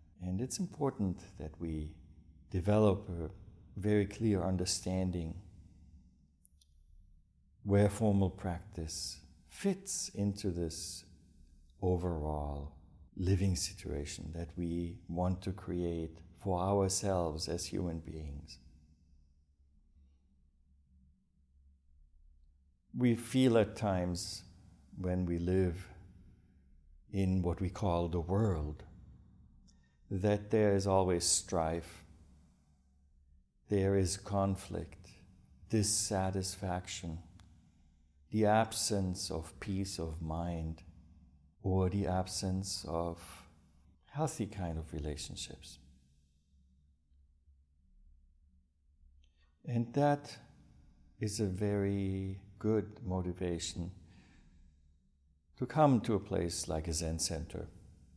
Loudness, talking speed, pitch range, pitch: -35 LUFS, 85 wpm, 75-95 Hz, 85 Hz